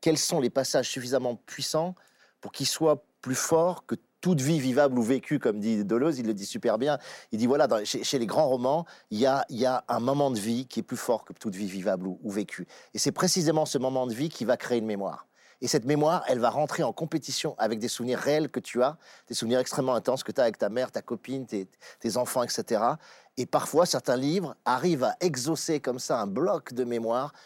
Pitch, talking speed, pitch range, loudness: 130 Hz, 240 wpm, 120-150 Hz, -28 LUFS